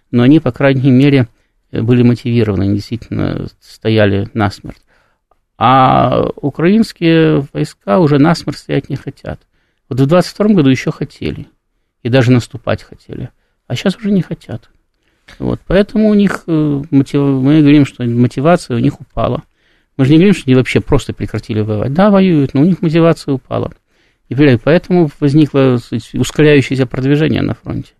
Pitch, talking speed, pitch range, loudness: 140 Hz, 150 wpm, 120-155 Hz, -12 LUFS